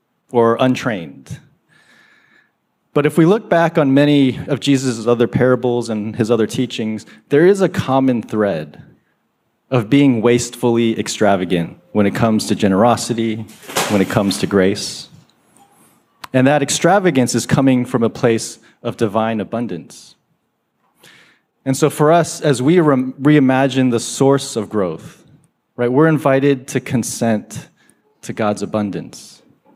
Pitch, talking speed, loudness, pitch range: 120 Hz, 135 wpm, -16 LUFS, 110-140 Hz